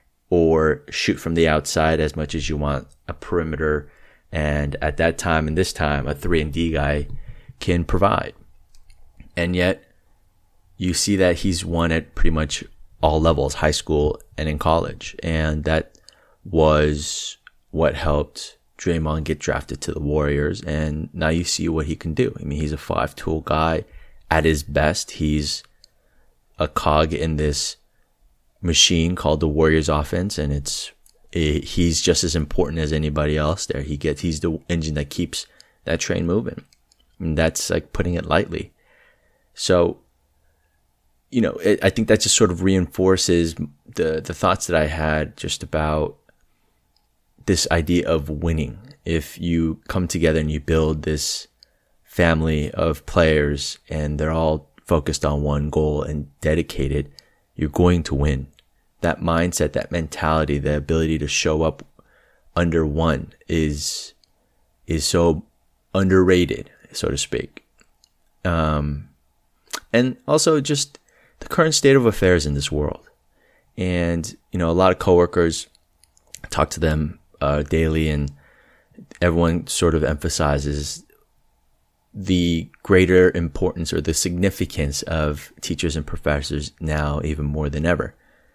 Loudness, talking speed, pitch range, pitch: -21 LUFS, 150 wpm, 75-85 Hz, 80 Hz